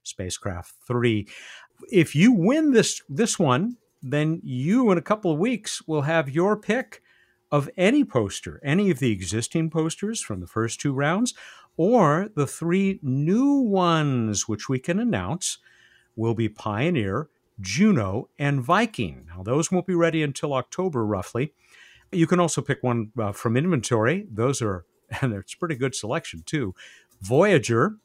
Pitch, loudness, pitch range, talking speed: 155 Hz, -24 LUFS, 120-190 Hz, 155 wpm